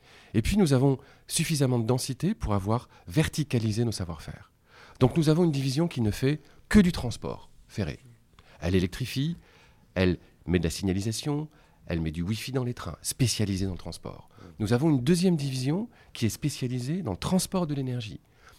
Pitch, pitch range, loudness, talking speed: 125 Hz, 100-150 Hz, -28 LUFS, 180 wpm